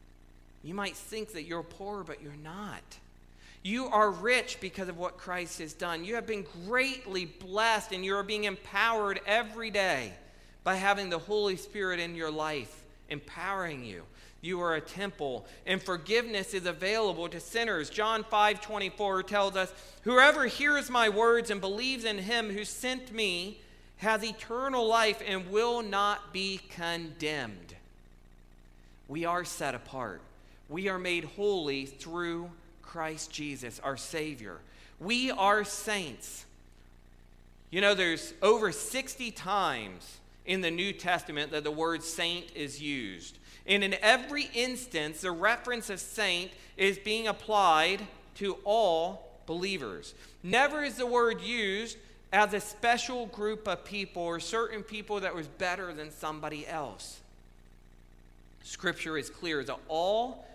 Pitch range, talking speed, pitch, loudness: 160-215 Hz, 145 wpm, 190 Hz, -31 LUFS